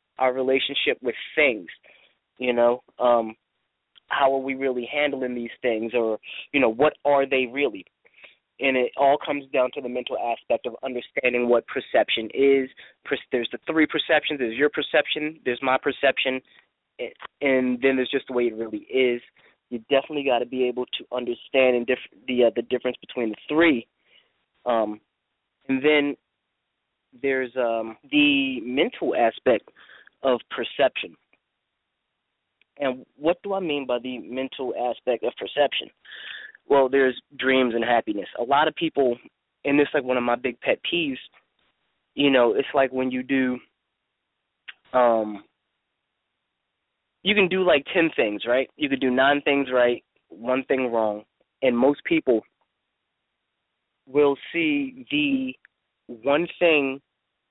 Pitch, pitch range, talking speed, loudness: 130 Hz, 120-145 Hz, 150 wpm, -23 LUFS